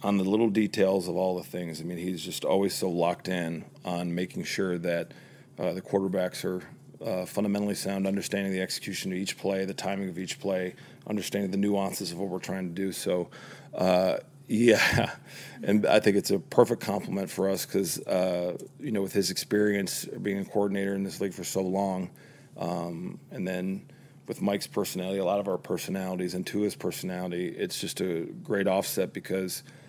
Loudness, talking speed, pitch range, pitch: -29 LUFS, 195 wpm, 90-100 Hz, 95 Hz